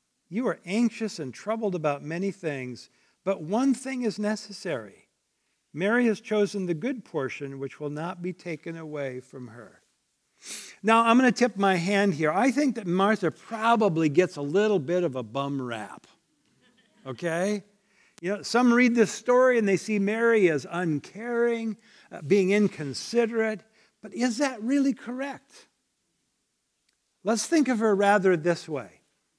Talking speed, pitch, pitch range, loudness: 155 wpm, 200 Hz, 165-230 Hz, -26 LUFS